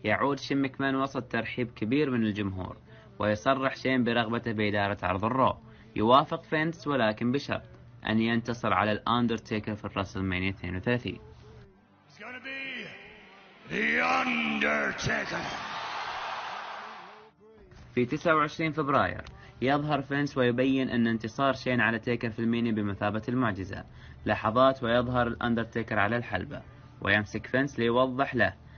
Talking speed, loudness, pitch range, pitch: 105 wpm, -28 LUFS, 110-135 Hz, 120 Hz